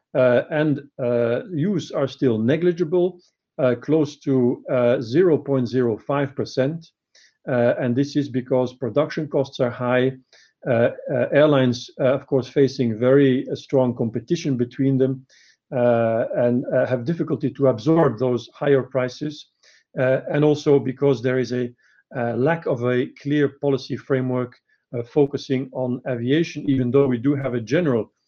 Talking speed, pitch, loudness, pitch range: 145 wpm, 130 Hz, -21 LUFS, 125-145 Hz